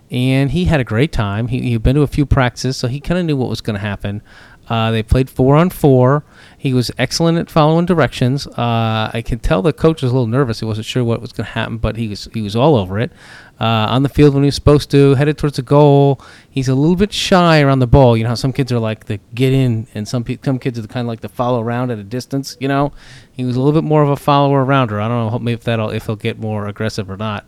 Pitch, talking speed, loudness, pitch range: 125 Hz, 285 wpm, -15 LUFS, 115-140 Hz